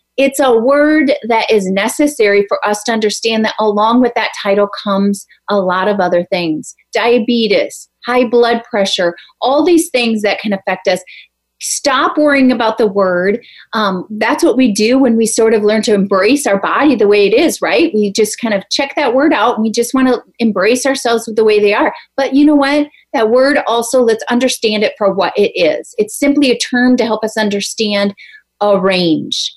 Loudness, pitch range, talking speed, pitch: -12 LUFS, 205-260 Hz, 205 wpm, 225 Hz